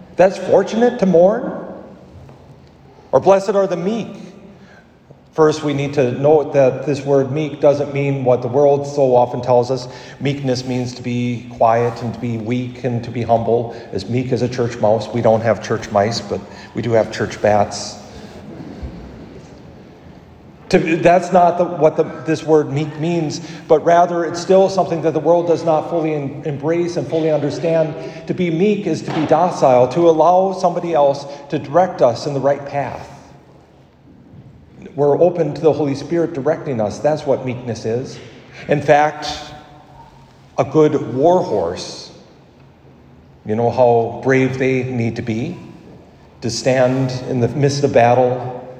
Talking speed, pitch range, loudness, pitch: 165 wpm, 125-160 Hz, -17 LUFS, 140 Hz